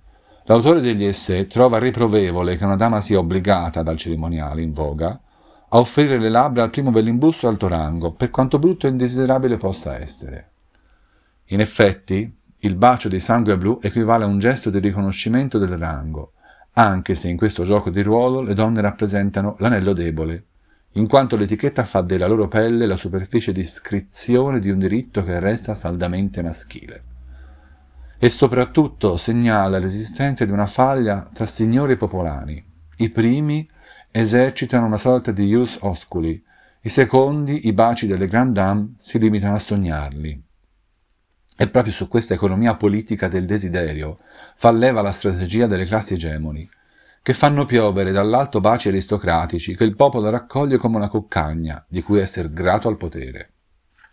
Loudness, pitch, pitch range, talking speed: -19 LUFS, 105 Hz, 90-115 Hz, 155 wpm